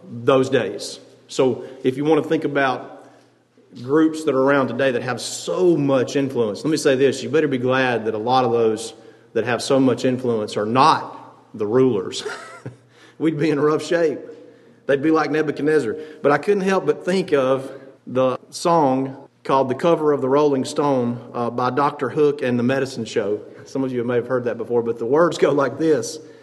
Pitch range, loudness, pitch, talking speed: 125-155 Hz, -20 LUFS, 135 Hz, 200 wpm